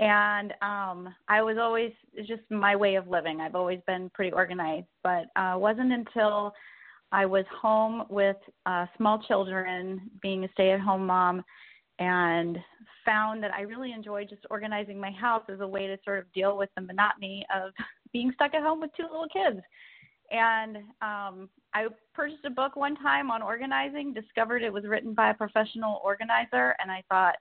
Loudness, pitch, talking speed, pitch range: -28 LUFS, 205 Hz, 185 wpm, 190-225 Hz